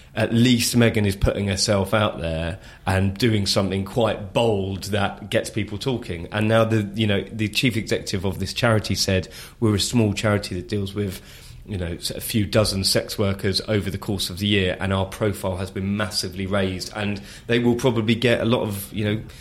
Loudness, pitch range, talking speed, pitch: -22 LUFS, 95-110 Hz, 205 wpm, 105 Hz